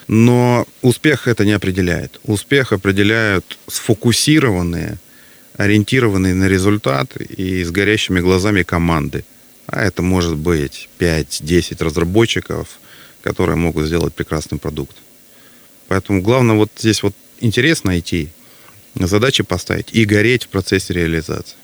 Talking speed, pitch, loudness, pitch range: 115 wpm, 100 Hz, -16 LUFS, 85-110 Hz